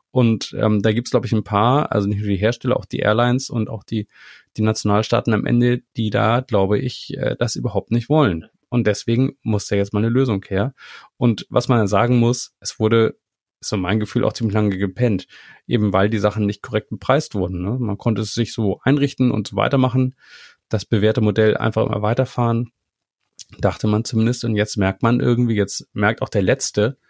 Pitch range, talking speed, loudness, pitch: 105-120 Hz, 210 wpm, -19 LUFS, 110 Hz